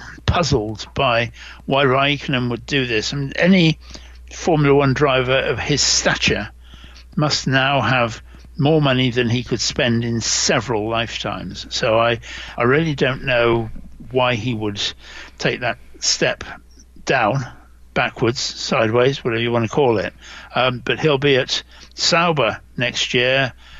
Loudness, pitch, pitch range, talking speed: -18 LUFS, 125 Hz, 110-135 Hz, 145 wpm